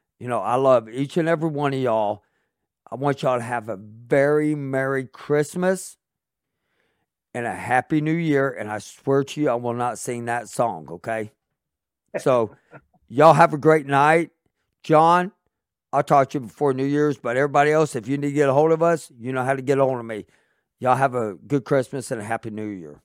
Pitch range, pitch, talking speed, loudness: 120-150 Hz, 135 Hz, 210 wpm, -21 LUFS